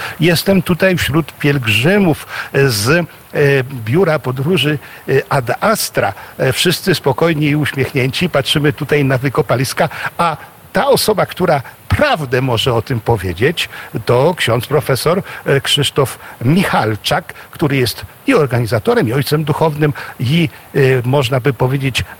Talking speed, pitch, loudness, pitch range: 115 wpm, 140 Hz, -14 LUFS, 130-155 Hz